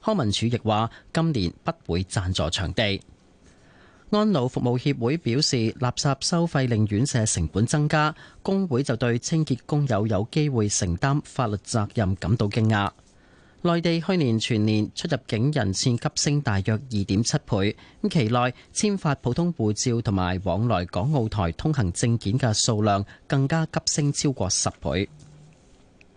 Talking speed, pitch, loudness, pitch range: 235 characters per minute, 120 Hz, -24 LUFS, 100-145 Hz